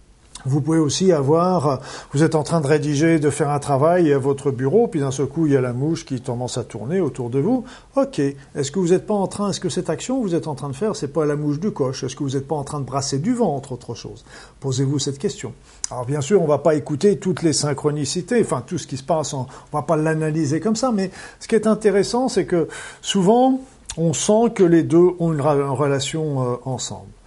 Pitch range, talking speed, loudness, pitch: 140-180 Hz, 260 wpm, -20 LUFS, 155 Hz